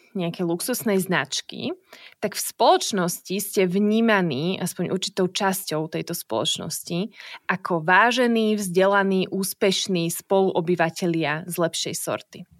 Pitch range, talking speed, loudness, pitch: 175-200 Hz, 100 wpm, -23 LUFS, 185 Hz